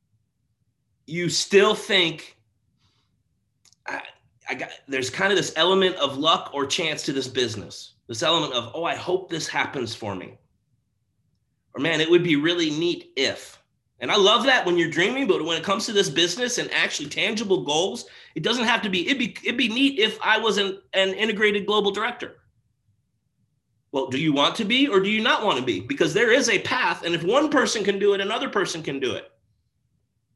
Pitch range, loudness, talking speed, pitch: 125-210 Hz, -22 LUFS, 200 wpm, 175 Hz